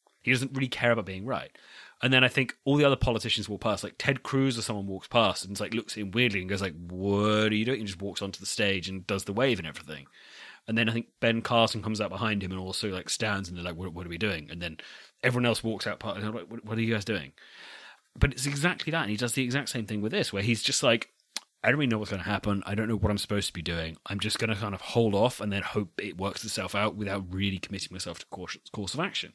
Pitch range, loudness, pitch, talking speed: 95-115 Hz, -29 LUFS, 105 Hz, 295 wpm